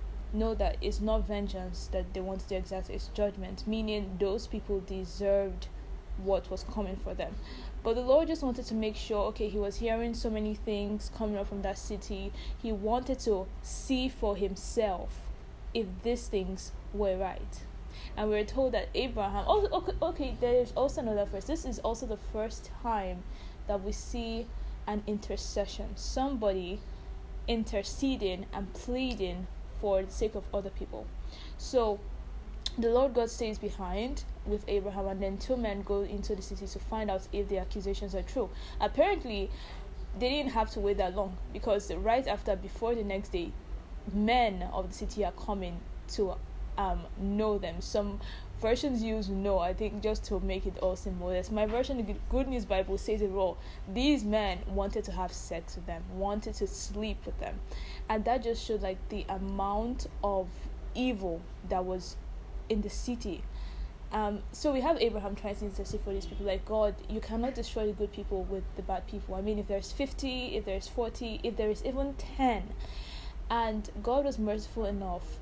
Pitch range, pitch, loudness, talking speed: 195-230 Hz, 210 Hz, -34 LUFS, 180 wpm